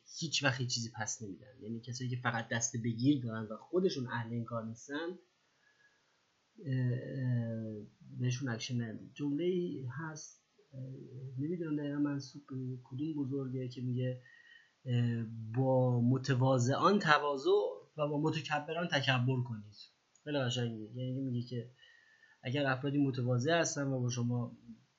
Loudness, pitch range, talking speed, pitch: -35 LUFS, 120-145 Hz, 120 wpm, 130 Hz